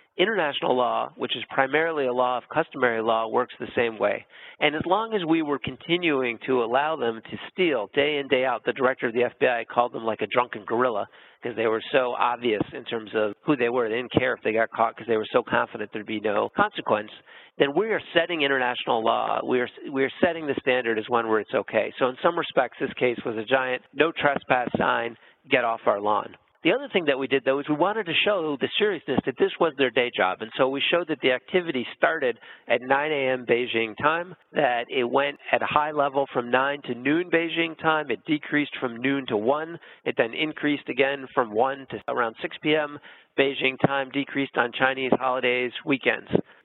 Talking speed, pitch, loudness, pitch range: 220 wpm, 135 Hz, -25 LUFS, 125-155 Hz